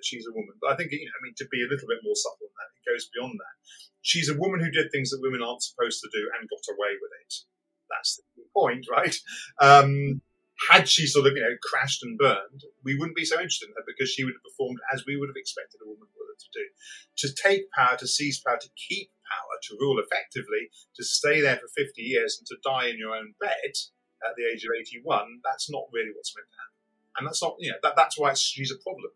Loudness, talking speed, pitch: -25 LUFS, 255 wpm, 165 Hz